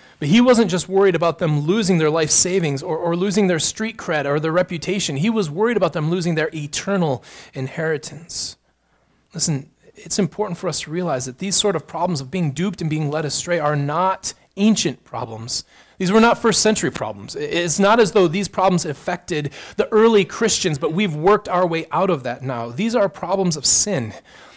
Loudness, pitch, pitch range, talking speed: -19 LUFS, 175 Hz, 155-195 Hz, 200 wpm